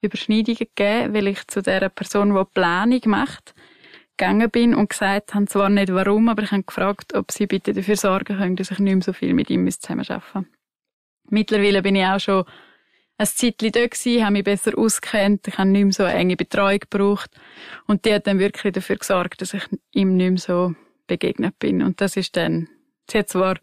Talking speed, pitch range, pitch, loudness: 200 wpm, 190-215 Hz, 200 Hz, -20 LUFS